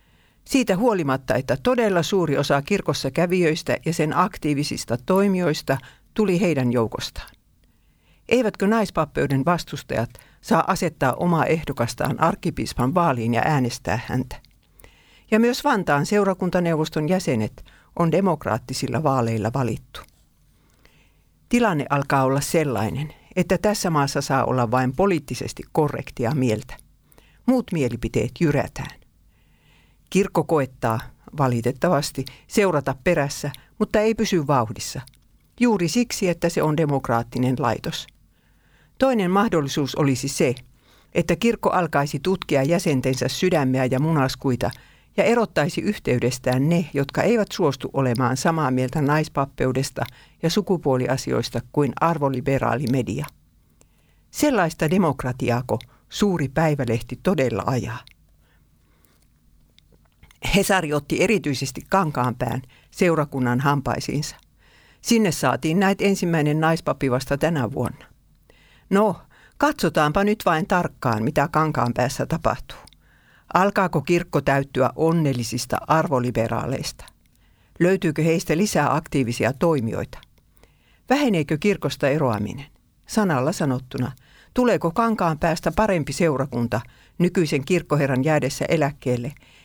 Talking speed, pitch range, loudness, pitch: 100 wpm, 130-175 Hz, -22 LUFS, 145 Hz